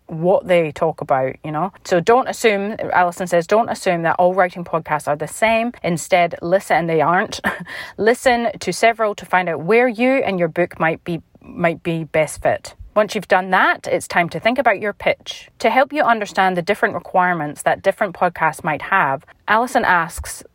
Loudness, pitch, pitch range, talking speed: -18 LUFS, 180 Hz, 165-220 Hz, 195 wpm